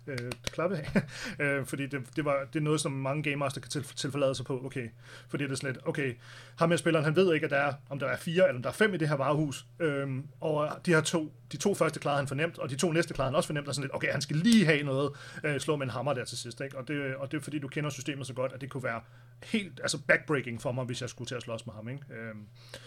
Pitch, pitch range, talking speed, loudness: 140 Hz, 130-155 Hz, 305 wpm, -31 LUFS